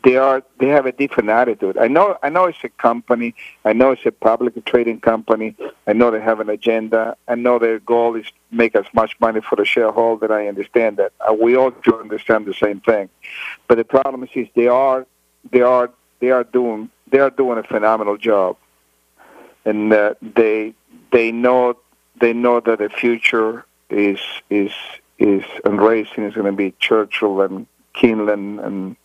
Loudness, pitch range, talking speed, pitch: -17 LUFS, 105-125 Hz, 190 wpm, 115 Hz